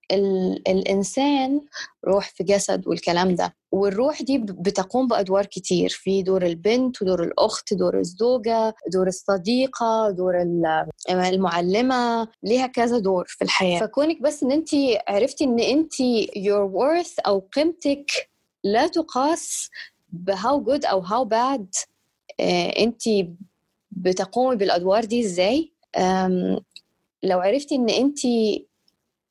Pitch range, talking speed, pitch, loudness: 190-265 Hz, 110 wpm, 215 Hz, -22 LUFS